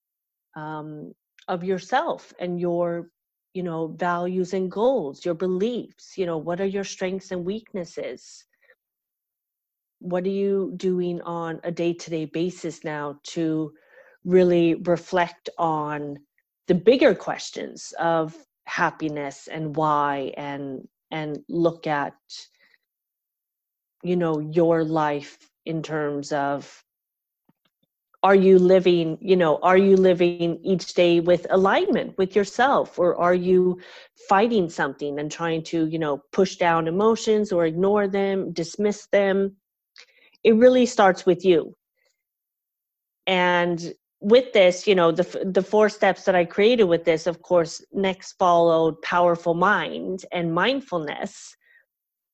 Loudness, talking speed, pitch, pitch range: -22 LUFS, 125 wpm, 175 Hz, 165-195 Hz